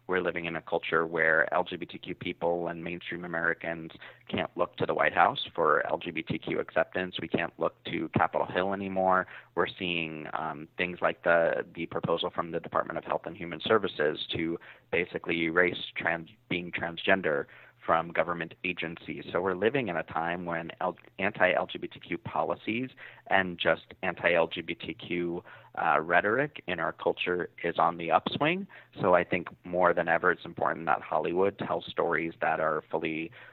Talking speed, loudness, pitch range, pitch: 165 wpm, -30 LUFS, 85-90 Hz, 85 Hz